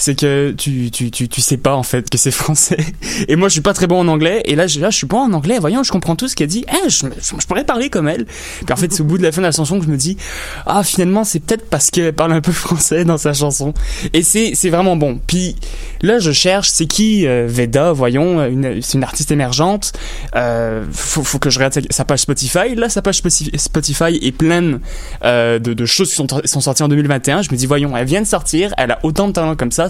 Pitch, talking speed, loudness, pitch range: 155 Hz, 265 wpm, -14 LUFS, 140-180 Hz